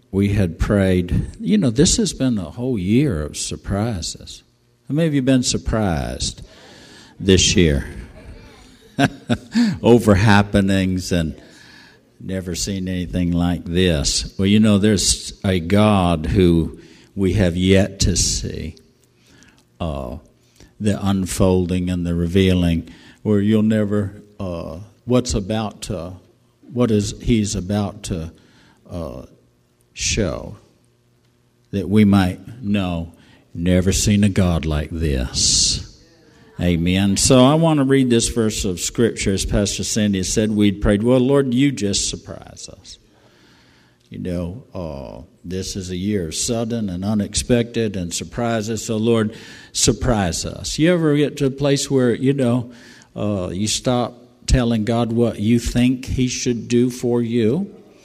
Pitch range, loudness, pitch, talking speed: 90-120 Hz, -19 LUFS, 100 Hz, 135 wpm